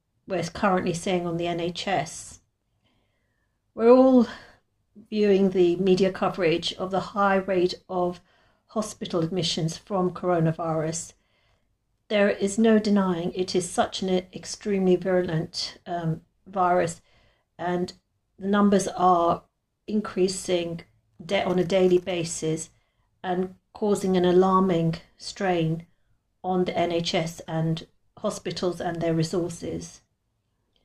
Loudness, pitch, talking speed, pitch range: -25 LUFS, 180 Hz, 110 wpm, 160-190 Hz